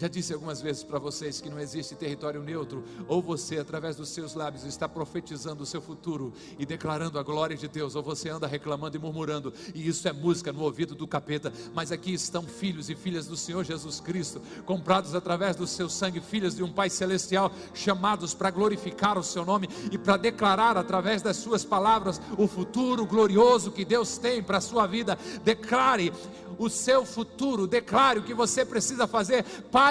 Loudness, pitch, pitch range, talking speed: -28 LUFS, 180 Hz, 155-210 Hz, 195 wpm